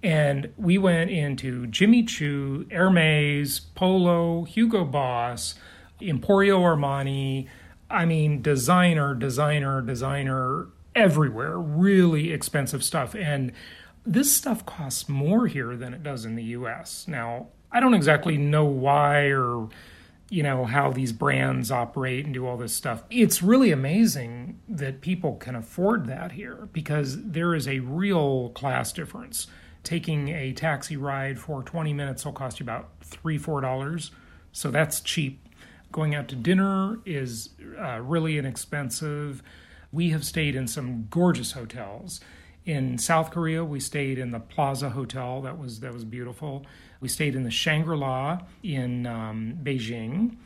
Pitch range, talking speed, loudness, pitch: 125-165 Hz, 145 wpm, -25 LUFS, 145 Hz